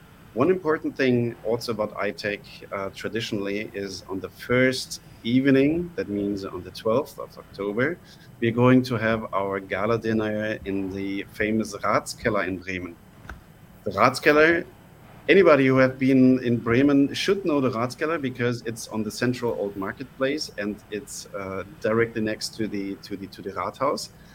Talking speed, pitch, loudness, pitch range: 160 wpm, 115 Hz, -24 LUFS, 100-130 Hz